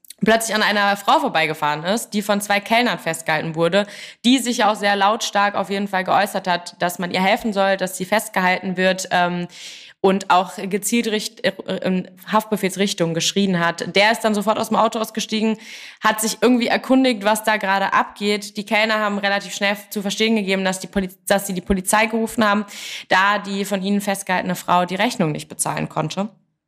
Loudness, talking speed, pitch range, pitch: -19 LUFS, 190 wpm, 185-215 Hz, 200 Hz